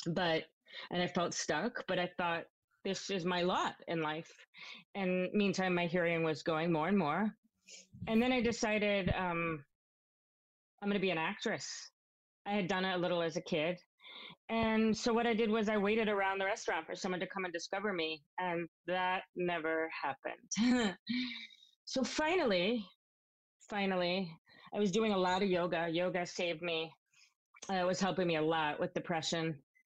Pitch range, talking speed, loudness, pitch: 170-205 Hz, 175 wpm, -35 LUFS, 180 Hz